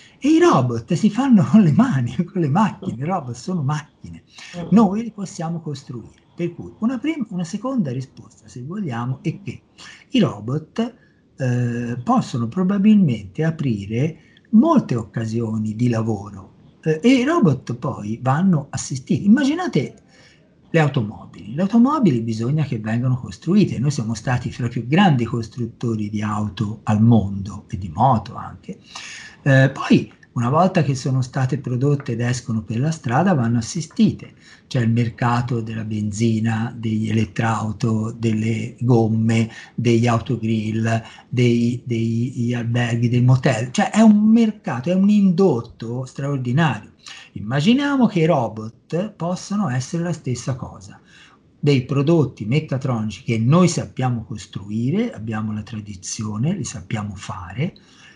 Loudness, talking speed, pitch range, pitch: -20 LUFS, 140 wpm, 115-170 Hz, 125 Hz